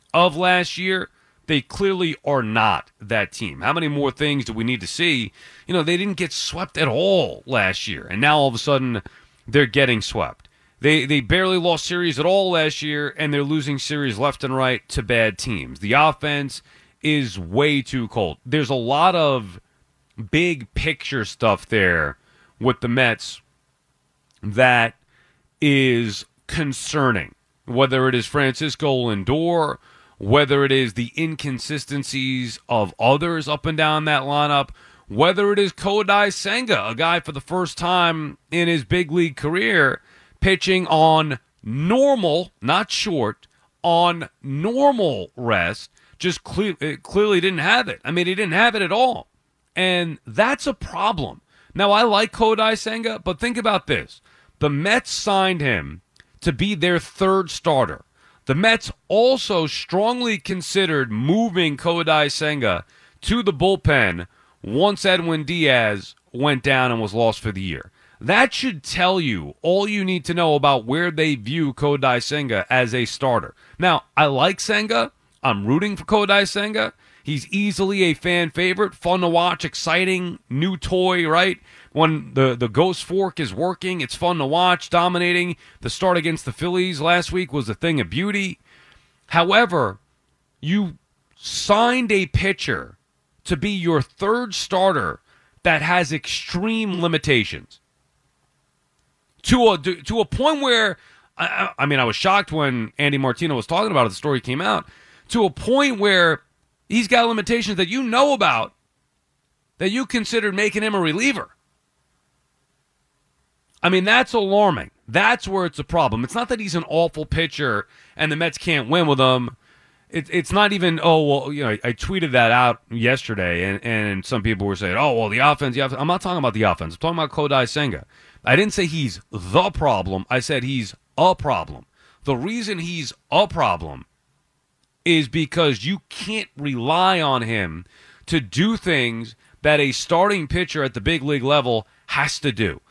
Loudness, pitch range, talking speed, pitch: -20 LUFS, 130-185 Hz, 165 wpm, 160 Hz